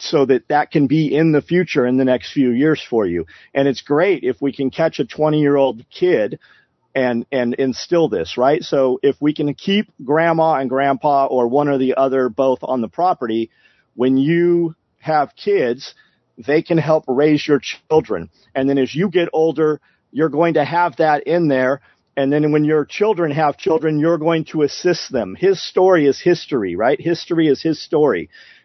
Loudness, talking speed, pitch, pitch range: -17 LUFS, 190 wpm, 150 Hz, 135-165 Hz